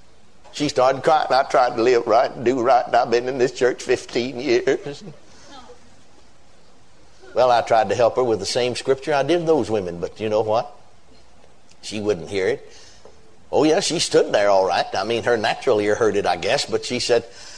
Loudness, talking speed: -20 LUFS, 210 wpm